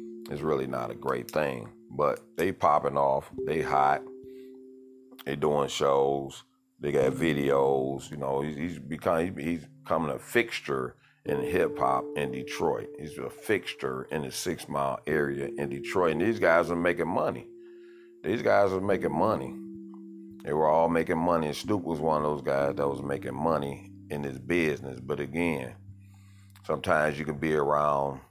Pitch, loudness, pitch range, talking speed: 75 Hz, -28 LUFS, 70-100 Hz, 170 wpm